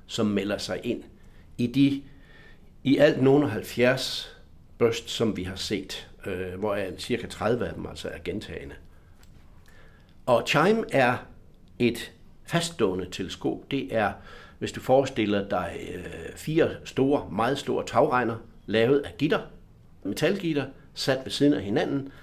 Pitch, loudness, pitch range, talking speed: 115 Hz, -26 LUFS, 100-140 Hz, 140 wpm